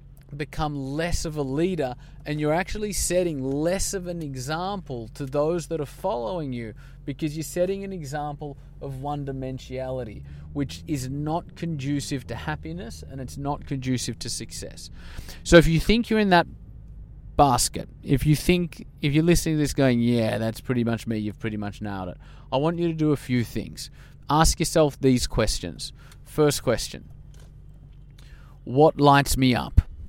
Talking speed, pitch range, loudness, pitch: 170 wpm, 120-155 Hz, -25 LUFS, 140 Hz